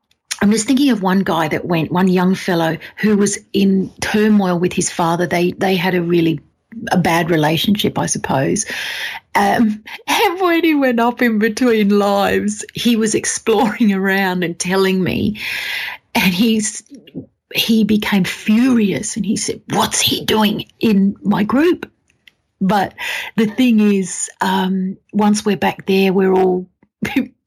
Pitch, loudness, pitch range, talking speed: 205 Hz, -16 LUFS, 185-225 Hz, 150 wpm